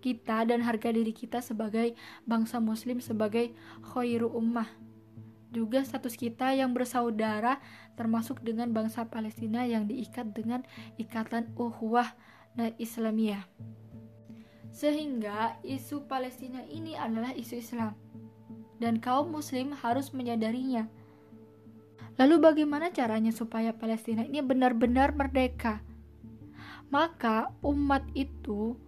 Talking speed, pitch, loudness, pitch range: 105 wpm, 230 Hz, -31 LUFS, 220-250 Hz